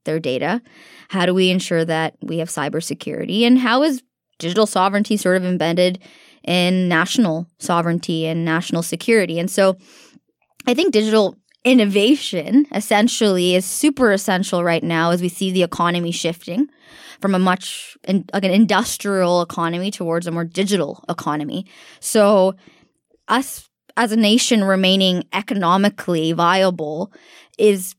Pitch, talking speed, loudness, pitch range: 185 Hz, 135 wpm, -18 LUFS, 170-215 Hz